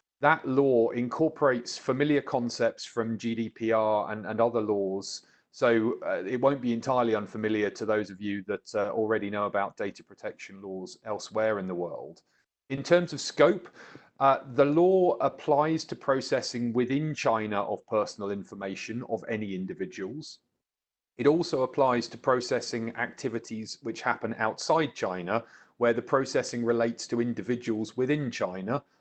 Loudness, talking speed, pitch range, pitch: -28 LUFS, 145 wpm, 110-135 Hz, 115 Hz